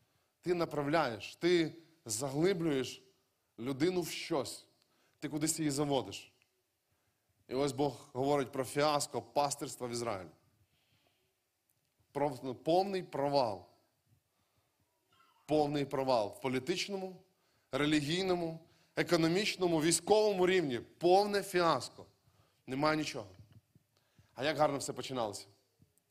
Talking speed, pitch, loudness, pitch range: 90 wpm, 145 Hz, -34 LUFS, 120-165 Hz